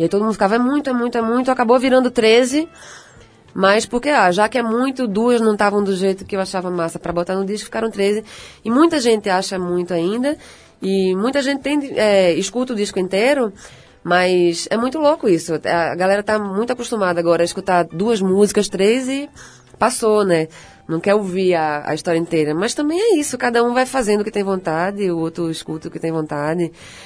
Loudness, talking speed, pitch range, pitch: -18 LUFS, 210 wpm, 175-240 Hz, 205 Hz